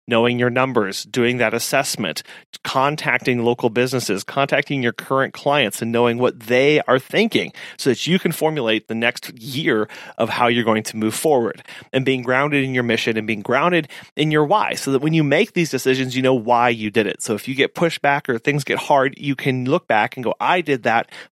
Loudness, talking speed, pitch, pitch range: -19 LUFS, 220 wpm, 130 Hz, 120-145 Hz